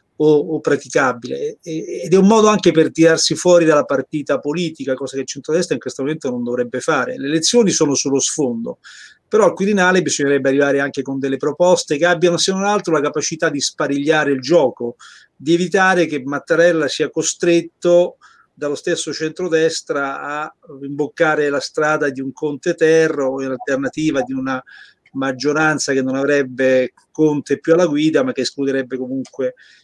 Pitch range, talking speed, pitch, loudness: 135-165 Hz, 165 wpm, 150 Hz, -17 LUFS